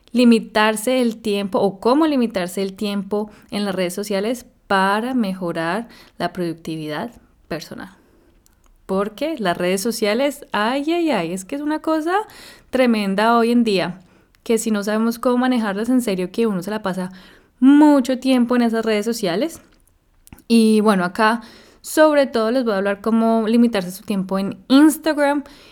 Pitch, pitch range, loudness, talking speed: 220 Hz, 195-255 Hz, -19 LUFS, 155 wpm